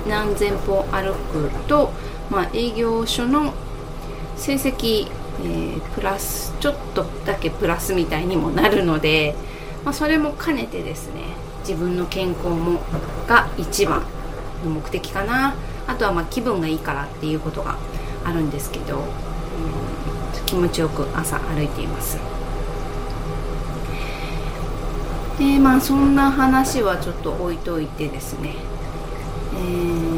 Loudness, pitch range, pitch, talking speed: -22 LUFS, 155-230 Hz, 175 Hz, 245 characters per minute